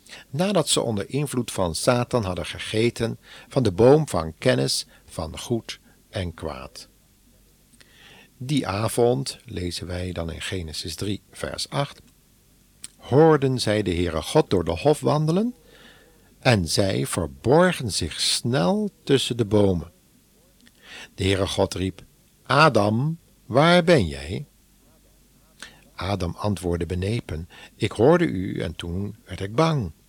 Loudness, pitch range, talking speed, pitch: -23 LUFS, 90-135 Hz, 125 wpm, 105 Hz